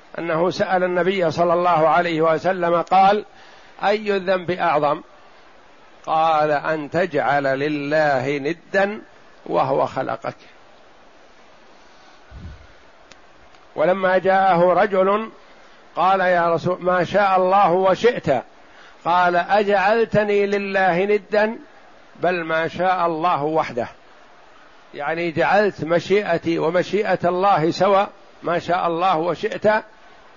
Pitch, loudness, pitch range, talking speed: 180 Hz, -19 LUFS, 165-195 Hz, 95 wpm